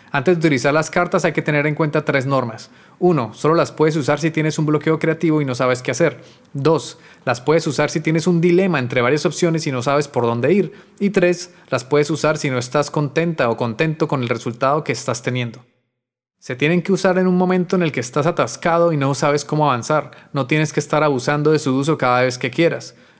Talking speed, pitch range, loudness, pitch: 235 wpm, 135-165 Hz, -18 LUFS, 150 Hz